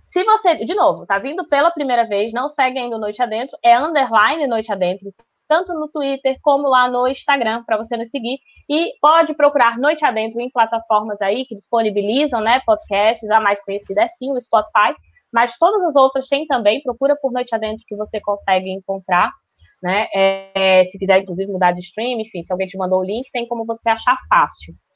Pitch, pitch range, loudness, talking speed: 230 Hz, 205-275 Hz, -17 LUFS, 195 wpm